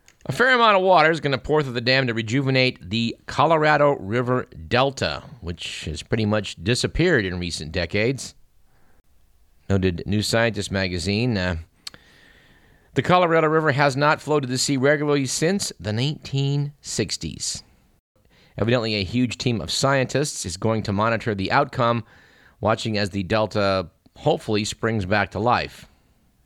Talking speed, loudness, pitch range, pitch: 145 wpm, -22 LUFS, 100-140 Hz, 115 Hz